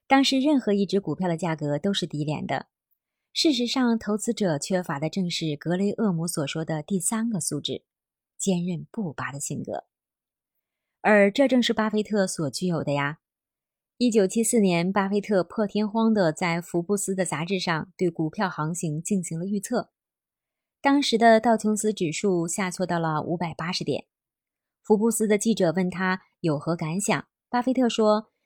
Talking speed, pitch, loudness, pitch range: 255 characters per minute, 190 Hz, -25 LUFS, 165-215 Hz